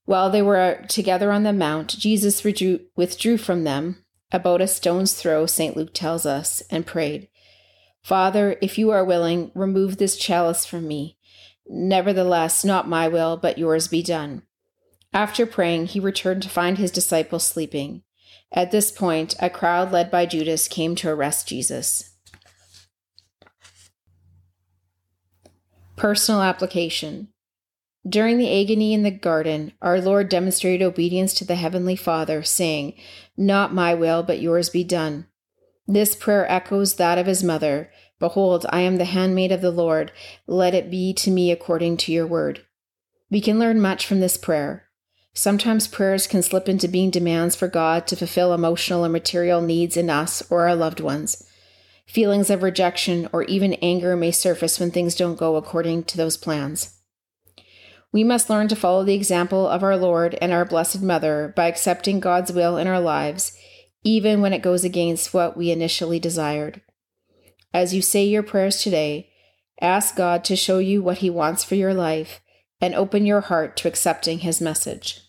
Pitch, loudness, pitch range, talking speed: 175 Hz, -21 LUFS, 160-190 Hz, 165 wpm